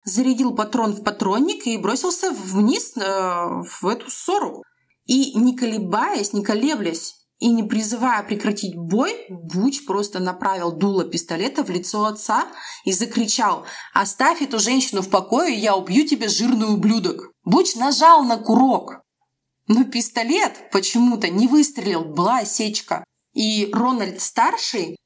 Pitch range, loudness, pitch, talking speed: 200-260 Hz, -20 LUFS, 225 Hz, 130 wpm